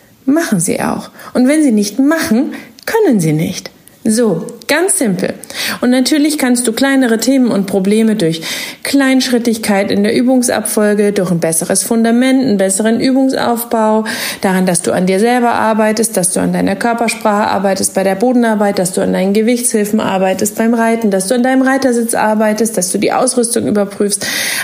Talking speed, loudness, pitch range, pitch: 170 wpm, -12 LUFS, 205-255 Hz, 225 Hz